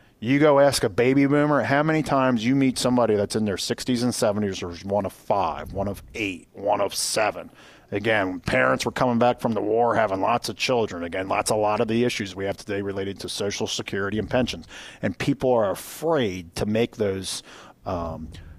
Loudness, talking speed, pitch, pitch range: -23 LUFS, 205 wpm, 110 Hz, 95-125 Hz